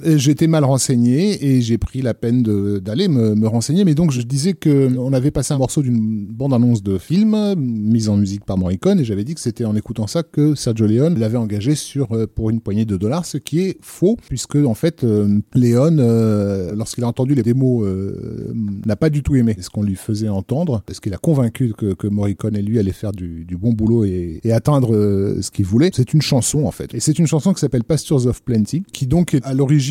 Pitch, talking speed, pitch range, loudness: 120 Hz, 235 wpm, 105-145 Hz, -17 LUFS